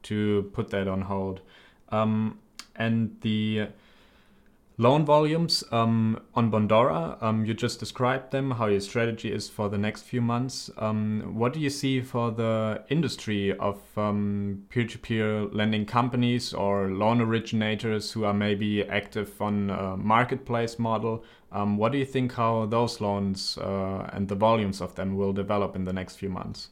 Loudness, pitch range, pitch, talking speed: -27 LUFS, 100-115 Hz, 110 Hz, 160 wpm